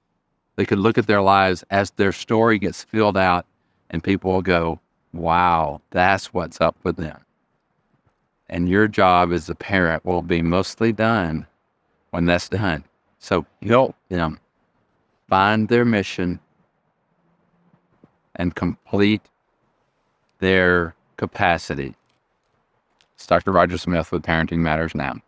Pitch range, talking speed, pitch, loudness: 85-100 Hz, 125 wpm, 90 Hz, -20 LUFS